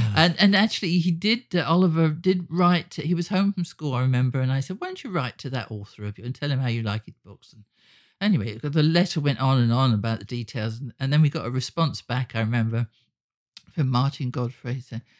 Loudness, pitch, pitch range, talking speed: -24 LUFS, 135 Hz, 120-175 Hz, 240 wpm